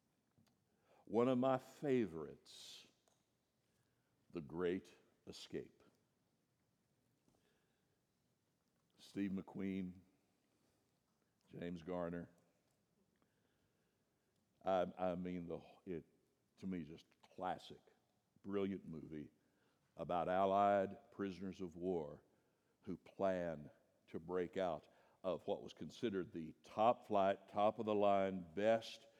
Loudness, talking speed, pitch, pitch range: -42 LUFS, 90 wpm, 95 Hz, 85-100 Hz